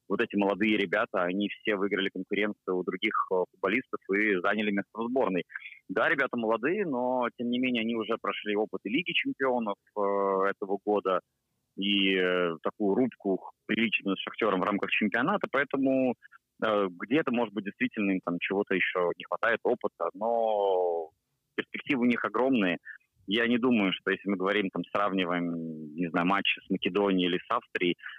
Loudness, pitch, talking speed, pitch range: -29 LUFS, 100 Hz, 165 wpm, 95-110 Hz